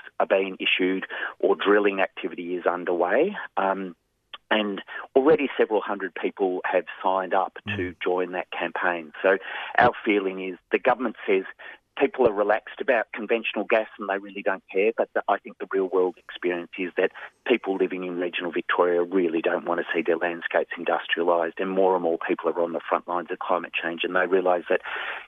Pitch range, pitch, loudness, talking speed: 90-100 Hz, 95 Hz, -25 LUFS, 190 wpm